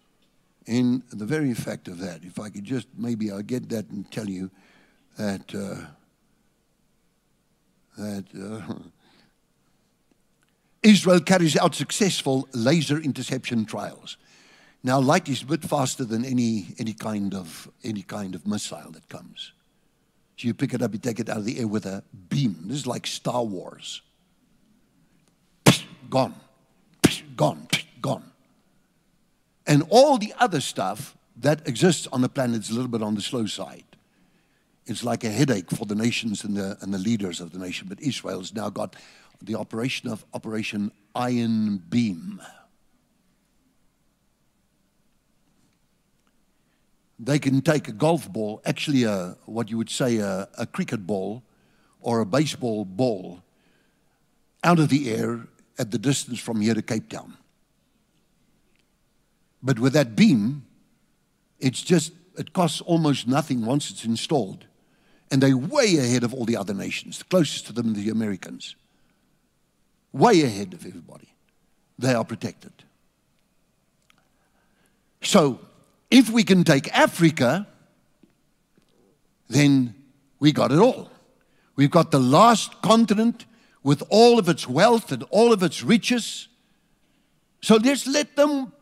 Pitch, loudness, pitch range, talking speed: 130 Hz, -23 LUFS, 110-160 Hz, 140 wpm